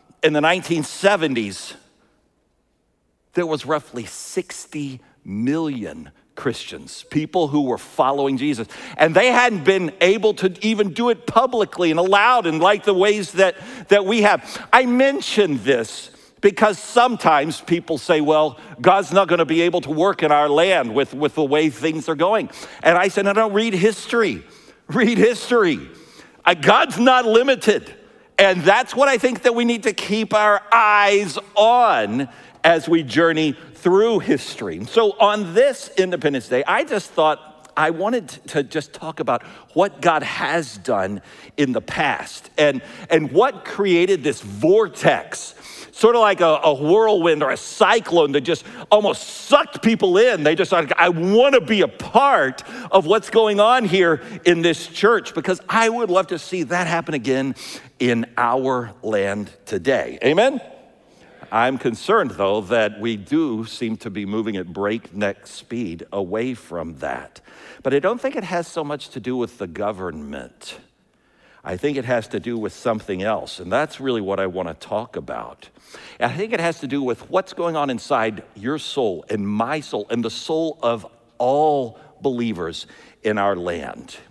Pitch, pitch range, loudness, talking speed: 170 Hz, 140-210 Hz, -19 LUFS, 165 wpm